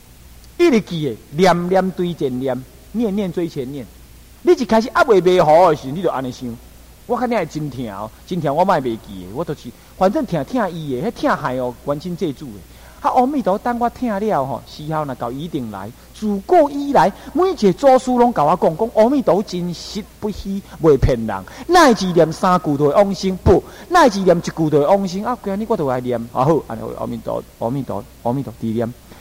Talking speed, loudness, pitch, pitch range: 300 characters per minute, -18 LUFS, 175 Hz, 135-220 Hz